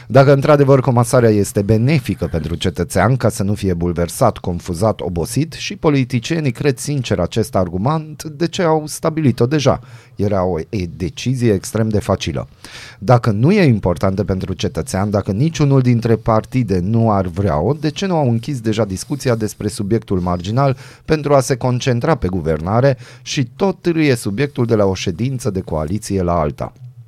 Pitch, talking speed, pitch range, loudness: 115 Hz, 165 wpm, 95-140 Hz, -17 LUFS